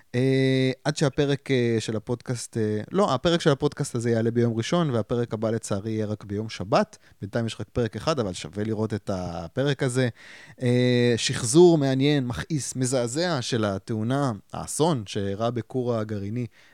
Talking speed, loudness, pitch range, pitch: 160 wpm, -25 LUFS, 110-135 Hz, 120 Hz